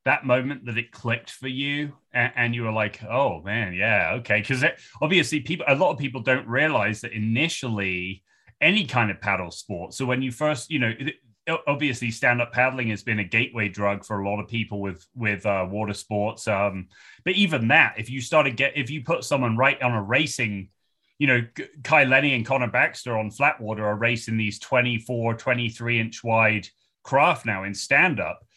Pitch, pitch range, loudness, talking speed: 120 Hz, 105-135 Hz, -23 LUFS, 205 wpm